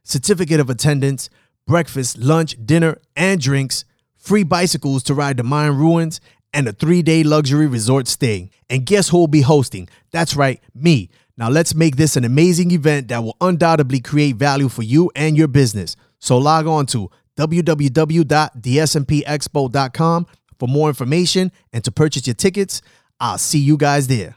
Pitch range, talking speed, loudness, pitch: 130-165 Hz, 165 wpm, -16 LUFS, 150 Hz